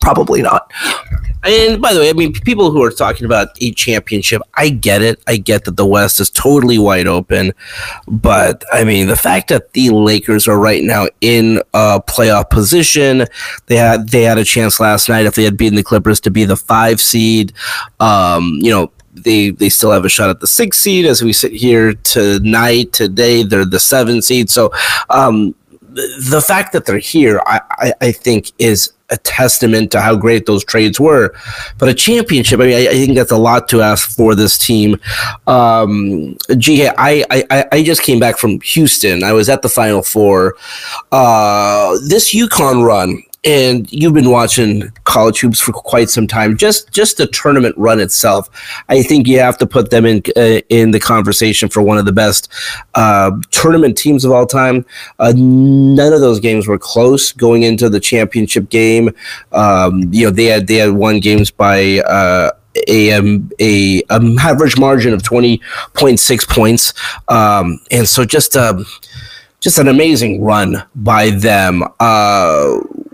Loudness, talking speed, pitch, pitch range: -10 LUFS, 185 wpm, 115 Hz, 105-125 Hz